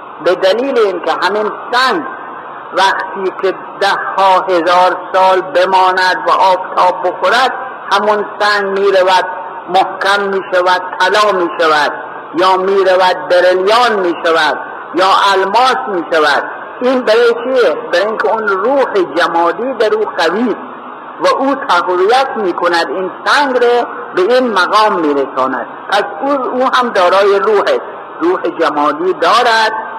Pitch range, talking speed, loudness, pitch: 185-240 Hz, 140 wpm, -12 LUFS, 195 Hz